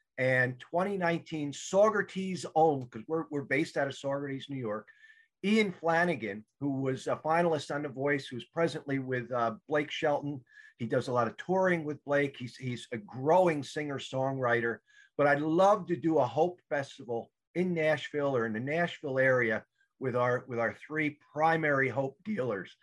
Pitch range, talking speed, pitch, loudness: 130-170 Hz, 170 wpm, 145 Hz, -31 LUFS